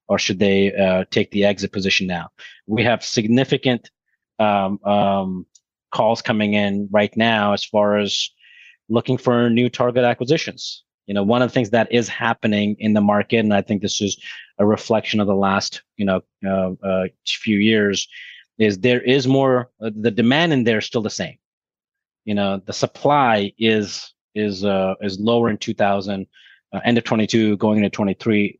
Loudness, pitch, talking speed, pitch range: -19 LUFS, 105 Hz, 180 wpm, 100-120 Hz